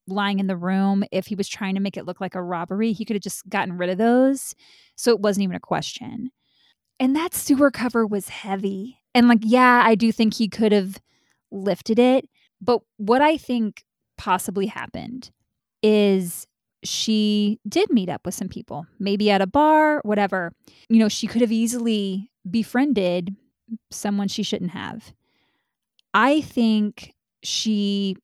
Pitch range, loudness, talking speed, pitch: 195-240 Hz, -21 LUFS, 170 wpm, 210 Hz